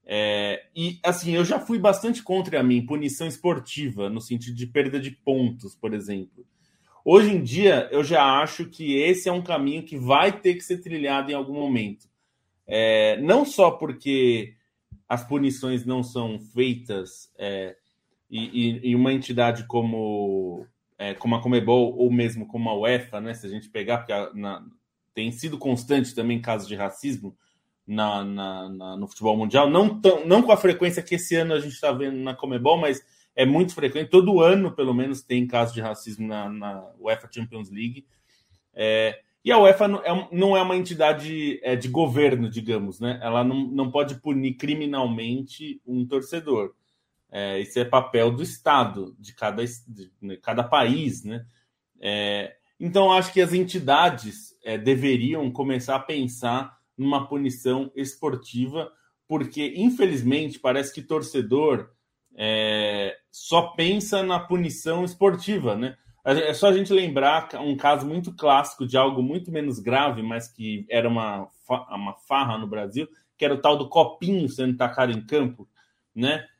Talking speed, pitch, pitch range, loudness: 165 wpm, 130 Hz, 115-155 Hz, -23 LUFS